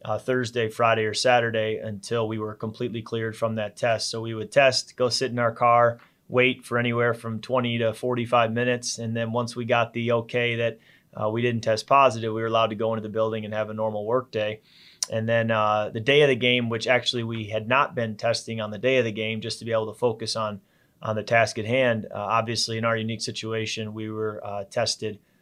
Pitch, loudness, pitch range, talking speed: 115 Hz, -24 LUFS, 110-120 Hz, 235 wpm